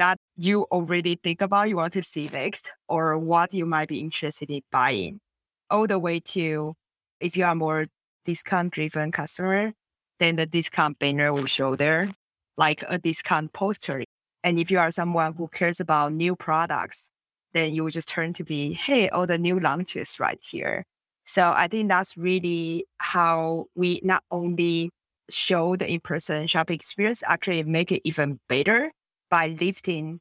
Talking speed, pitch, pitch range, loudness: 165 wpm, 170 Hz, 155-180 Hz, -25 LUFS